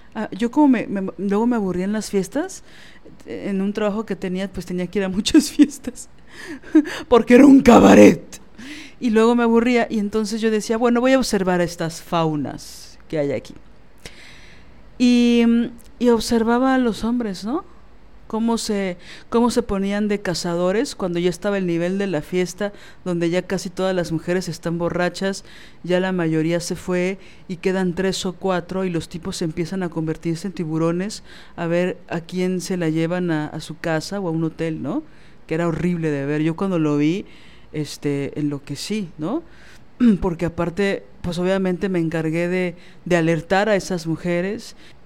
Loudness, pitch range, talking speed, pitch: -20 LUFS, 170-220 Hz, 175 wpm, 185 Hz